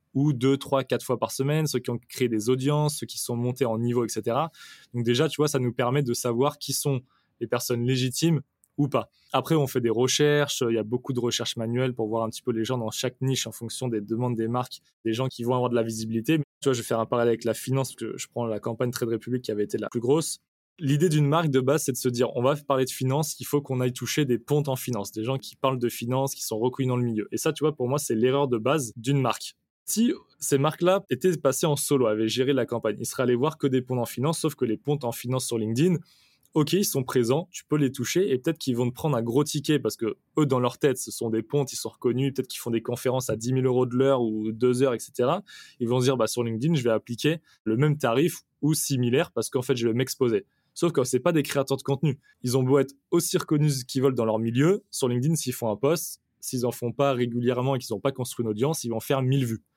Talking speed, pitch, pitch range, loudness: 280 wpm, 130 Hz, 120-145 Hz, -26 LUFS